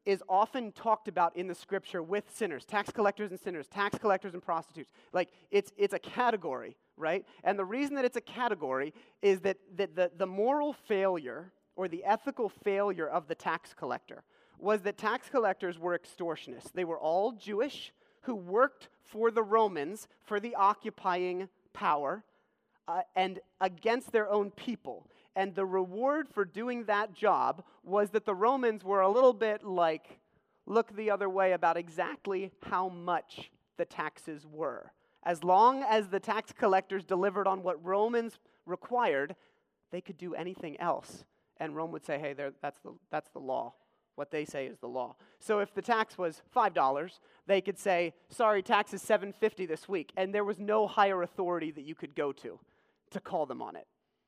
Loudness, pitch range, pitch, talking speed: -32 LUFS, 180-215 Hz, 195 Hz, 180 wpm